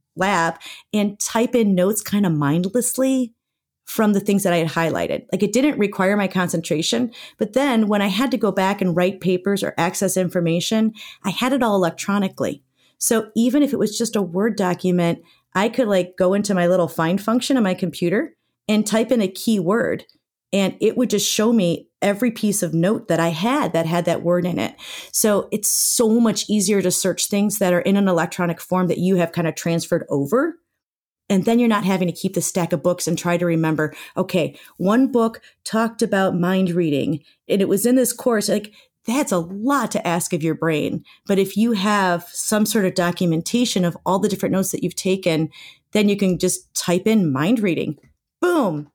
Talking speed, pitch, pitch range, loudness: 205 wpm, 195 Hz, 175-220 Hz, -20 LUFS